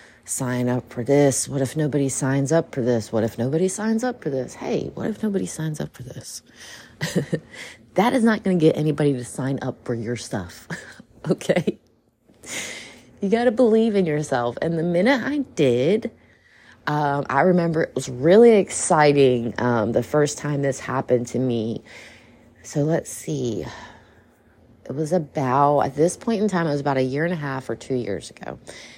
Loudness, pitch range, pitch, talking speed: -22 LUFS, 125-175 Hz, 145 Hz, 185 wpm